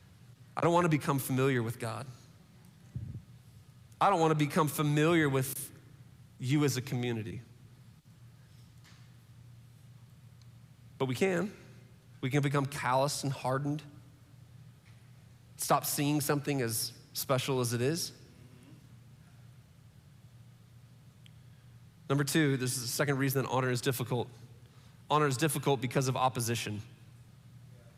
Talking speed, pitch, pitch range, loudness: 115 wpm, 130 Hz, 125-140 Hz, -31 LUFS